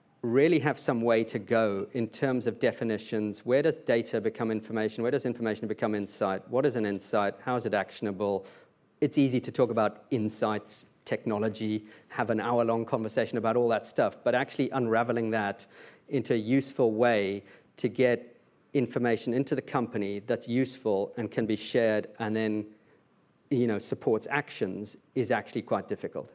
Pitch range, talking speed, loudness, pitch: 105-120 Hz, 170 wpm, -29 LUFS, 115 Hz